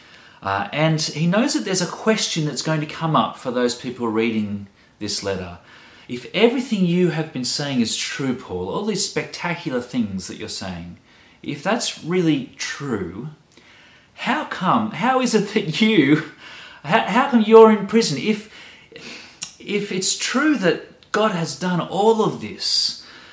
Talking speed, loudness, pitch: 160 wpm, -20 LUFS, 160 Hz